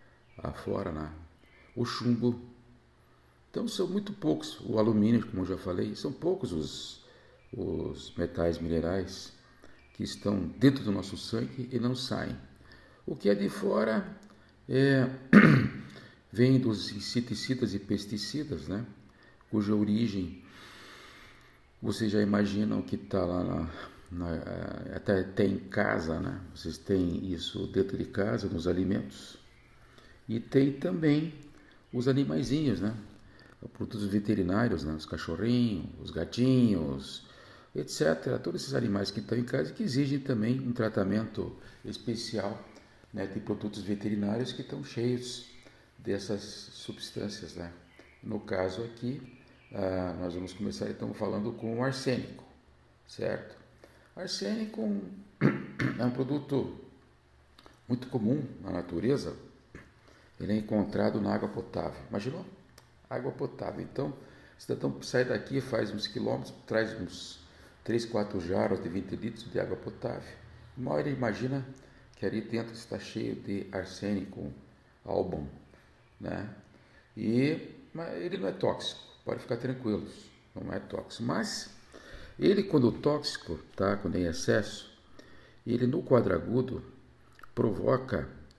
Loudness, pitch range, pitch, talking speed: -32 LUFS, 90-125 Hz, 105 Hz, 125 wpm